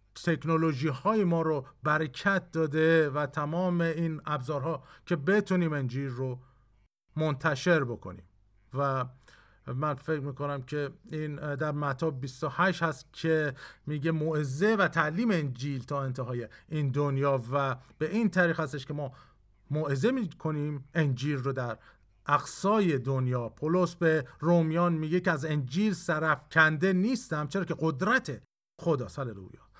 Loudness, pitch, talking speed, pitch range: -29 LUFS, 150 Hz, 130 wpm, 140-165 Hz